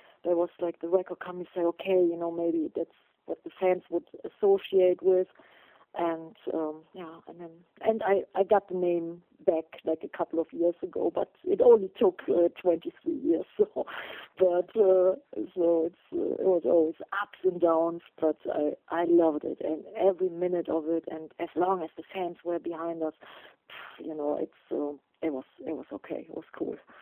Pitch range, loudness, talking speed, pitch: 165-195 Hz, -29 LUFS, 195 wpm, 175 Hz